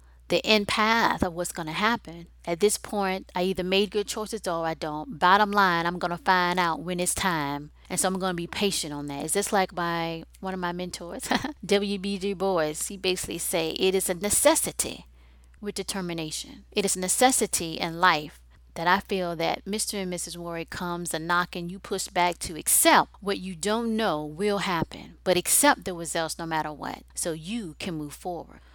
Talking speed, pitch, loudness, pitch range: 205 wpm, 180 Hz, -26 LUFS, 165-200 Hz